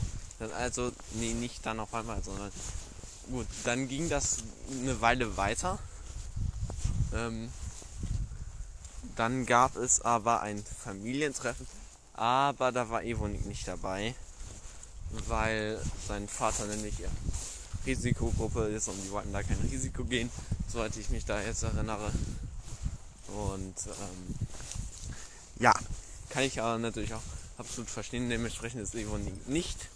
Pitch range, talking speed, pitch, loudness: 95-115 Hz, 125 wpm, 110 Hz, -34 LUFS